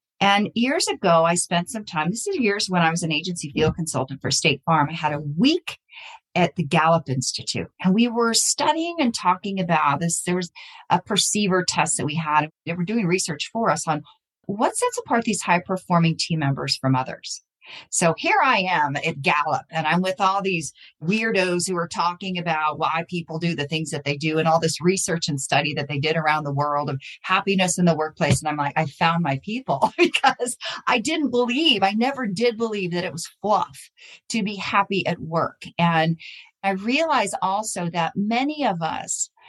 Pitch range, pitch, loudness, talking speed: 155-205 Hz, 175 Hz, -22 LUFS, 205 wpm